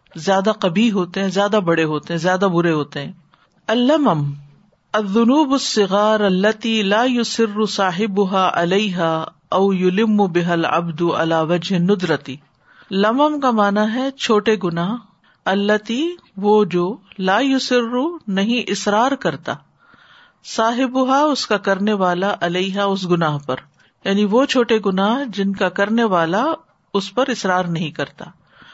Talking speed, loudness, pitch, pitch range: 135 wpm, -18 LUFS, 200 Hz, 175-225 Hz